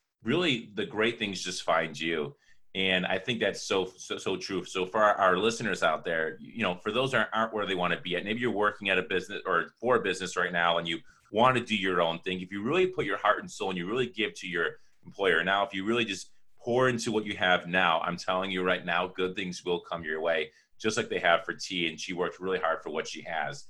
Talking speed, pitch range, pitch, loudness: 270 wpm, 90-105 Hz, 95 Hz, -29 LUFS